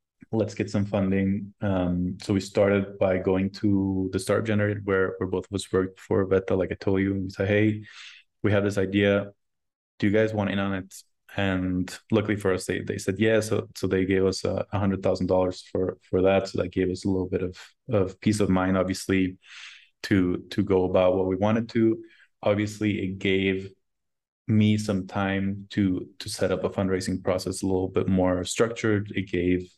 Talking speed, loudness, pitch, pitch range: 210 wpm, -26 LUFS, 95 Hz, 95-105 Hz